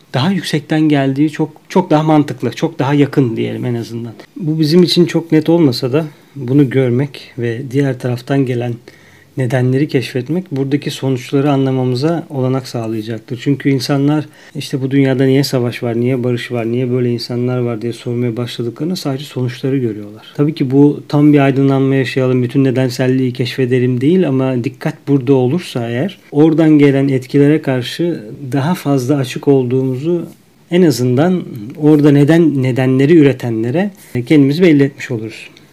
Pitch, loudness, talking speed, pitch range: 135 Hz, -14 LUFS, 150 wpm, 125-150 Hz